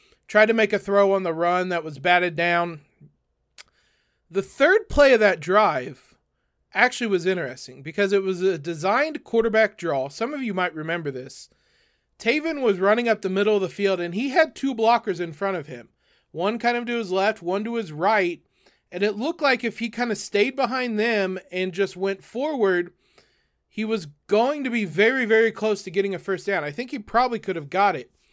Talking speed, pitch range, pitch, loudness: 210 wpm, 180-230 Hz, 200 Hz, -23 LUFS